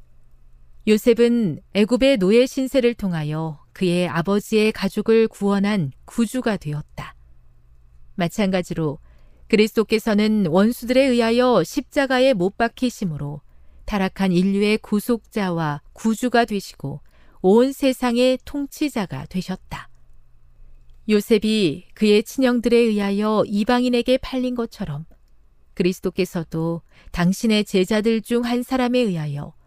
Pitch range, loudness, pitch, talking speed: 160-235 Hz, -20 LUFS, 205 Hz, 265 characters per minute